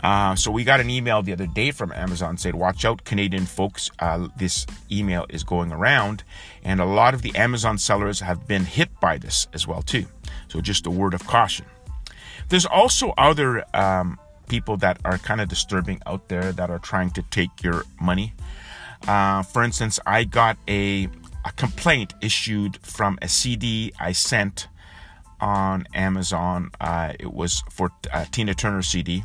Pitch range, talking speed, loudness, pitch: 90-100 Hz, 175 wpm, -22 LUFS, 95 Hz